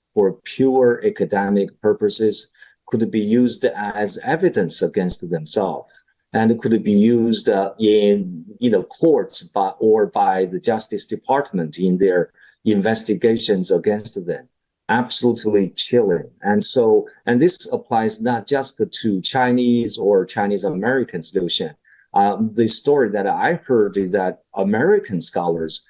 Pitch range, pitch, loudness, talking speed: 100-120 Hz, 110 Hz, -18 LUFS, 130 wpm